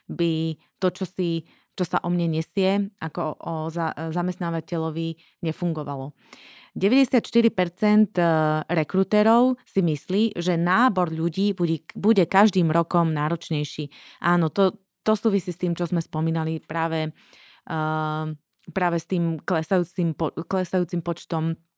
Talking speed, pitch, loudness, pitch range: 115 wpm, 170 Hz, -24 LUFS, 160-190 Hz